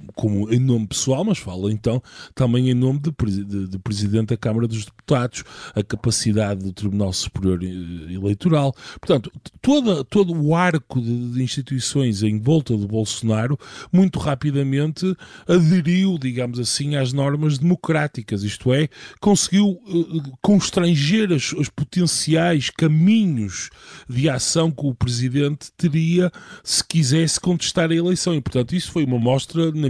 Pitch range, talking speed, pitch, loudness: 115-165 Hz, 145 wpm, 140 Hz, -20 LUFS